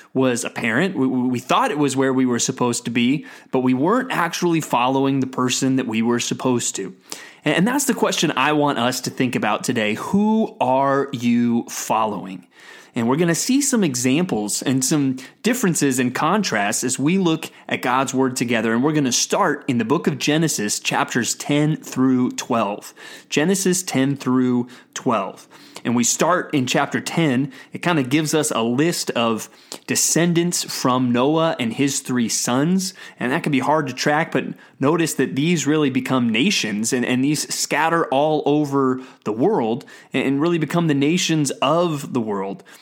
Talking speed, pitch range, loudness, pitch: 180 wpm, 125-160 Hz, -20 LUFS, 135 Hz